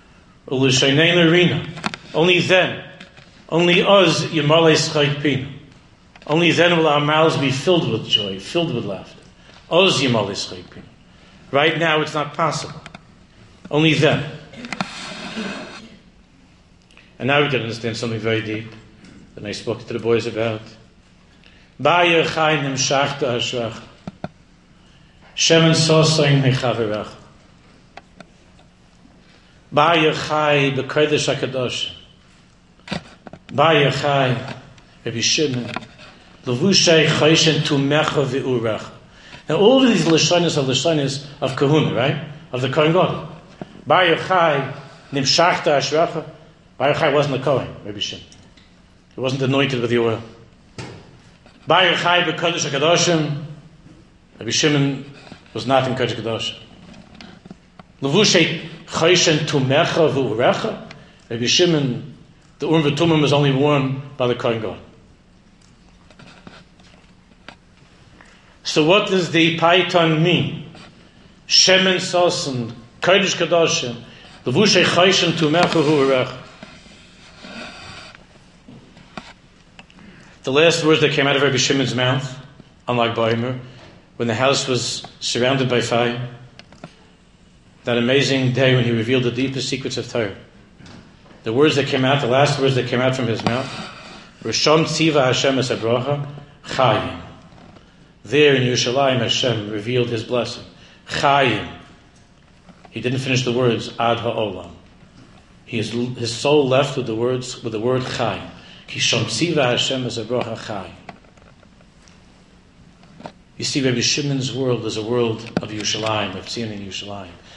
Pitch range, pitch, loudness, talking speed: 120-160 Hz, 135 Hz, -18 LUFS, 110 wpm